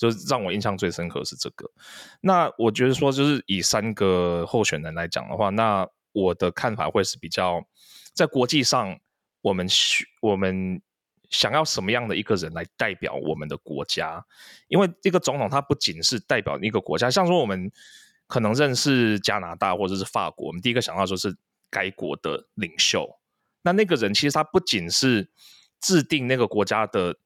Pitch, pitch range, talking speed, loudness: 110 Hz, 95-145 Hz, 280 characters per minute, -23 LUFS